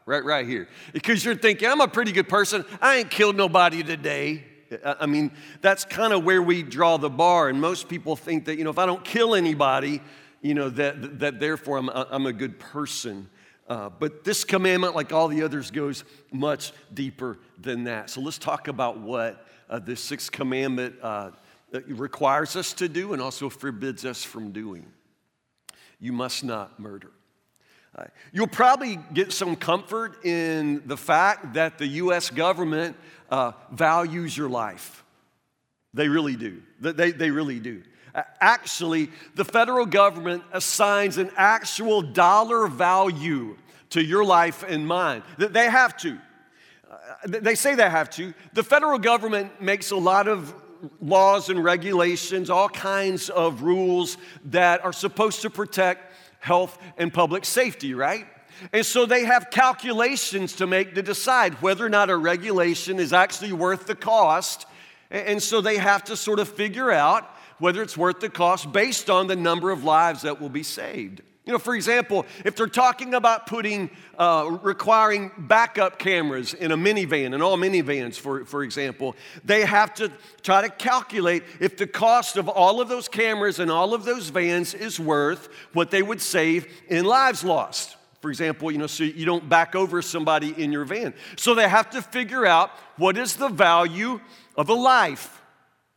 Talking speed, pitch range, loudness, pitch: 170 wpm, 150-205 Hz, -22 LUFS, 175 Hz